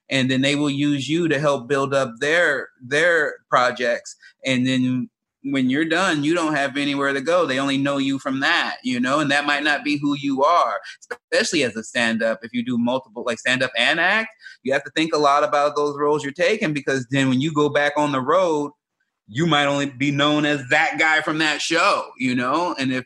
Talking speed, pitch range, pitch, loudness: 230 wpm, 135-160 Hz, 145 Hz, -20 LUFS